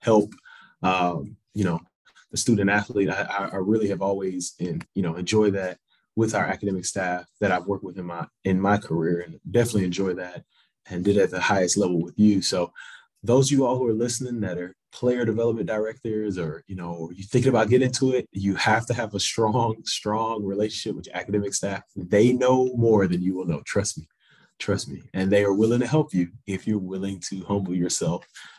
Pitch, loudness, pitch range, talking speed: 100 Hz, -24 LUFS, 95-115 Hz, 210 wpm